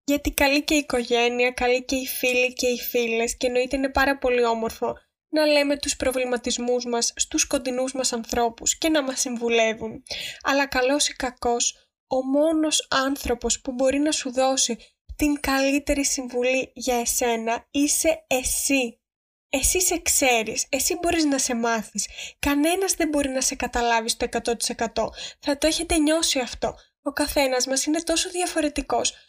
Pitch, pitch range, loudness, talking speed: 265 Hz, 245-290 Hz, -23 LUFS, 160 wpm